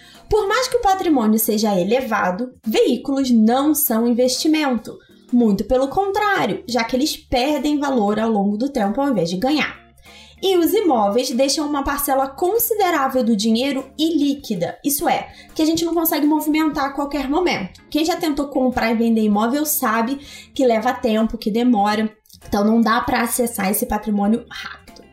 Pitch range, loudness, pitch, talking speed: 225-300 Hz, -19 LUFS, 260 Hz, 165 wpm